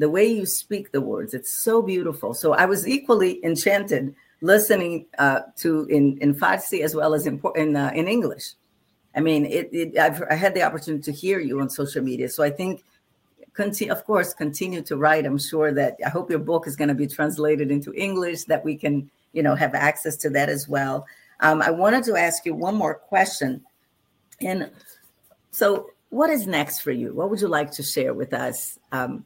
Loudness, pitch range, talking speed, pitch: -22 LUFS, 145-190 Hz, 210 wpm, 155 Hz